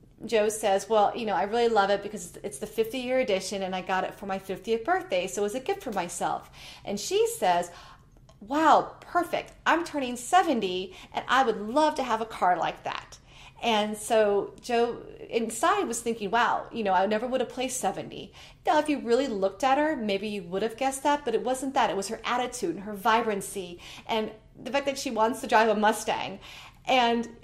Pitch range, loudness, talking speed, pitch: 200-260 Hz, -27 LUFS, 215 wpm, 225 Hz